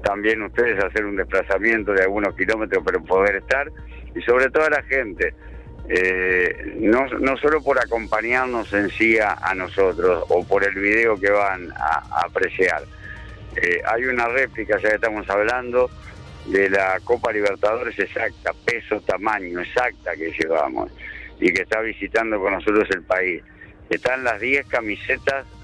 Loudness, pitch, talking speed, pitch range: -20 LUFS, 110 Hz, 155 wpm, 100-125 Hz